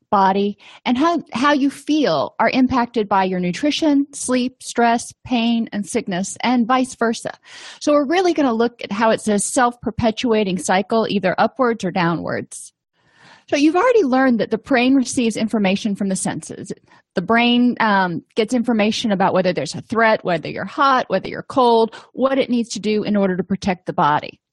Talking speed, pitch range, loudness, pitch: 185 wpm, 200-255 Hz, -18 LUFS, 230 Hz